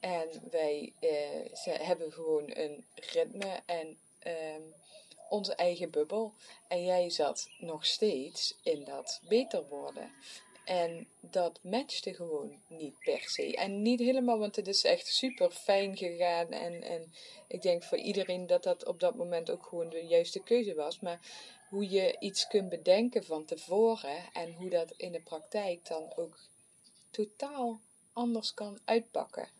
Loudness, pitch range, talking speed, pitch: -34 LUFS, 175-290 Hz, 155 wpm, 215 Hz